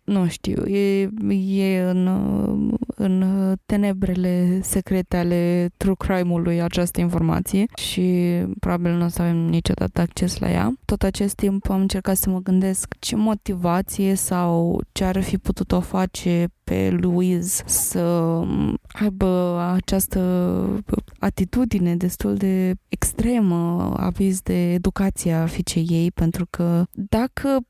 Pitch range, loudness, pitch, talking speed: 175-195 Hz, -21 LUFS, 185 Hz, 125 wpm